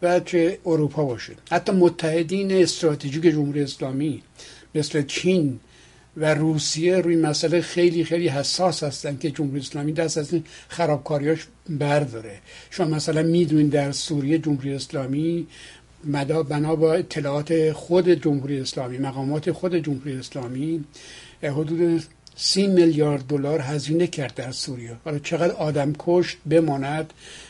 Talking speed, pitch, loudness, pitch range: 125 wpm, 155 Hz, -23 LUFS, 145-170 Hz